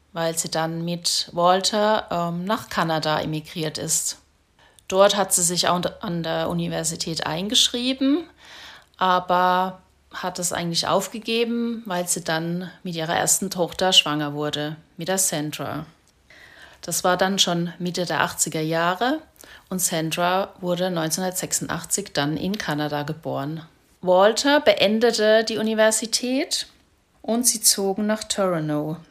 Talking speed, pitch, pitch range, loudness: 125 wpm, 180 Hz, 165-200 Hz, -22 LUFS